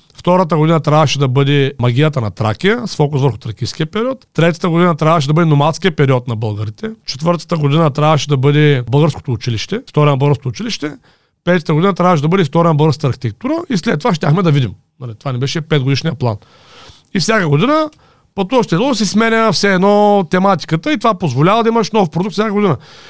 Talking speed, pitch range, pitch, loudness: 185 wpm, 140-200 Hz, 160 Hz, -14 LUFS